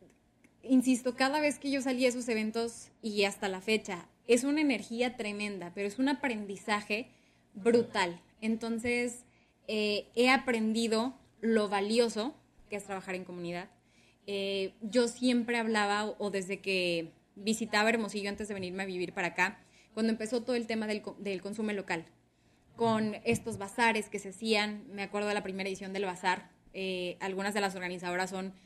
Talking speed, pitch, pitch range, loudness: 165 wpm, 210 Hz, 195-230 Hz, -32 LUFS